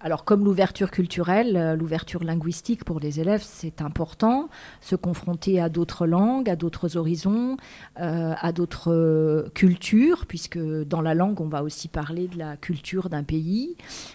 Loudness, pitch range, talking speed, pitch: -24 LUFS, 160-190 Hz, 155 wpm, 170 Hz